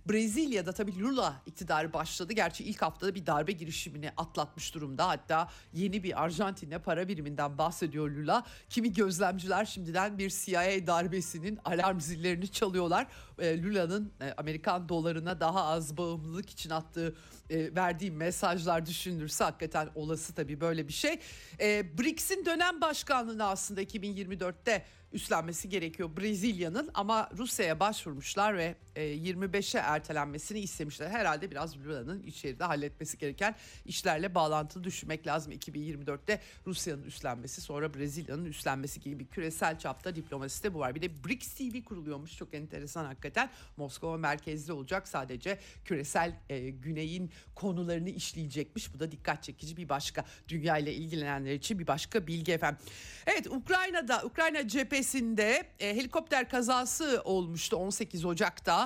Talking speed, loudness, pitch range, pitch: 125 wpm, -34 LUFS, 155-200 Hz, 175 Hz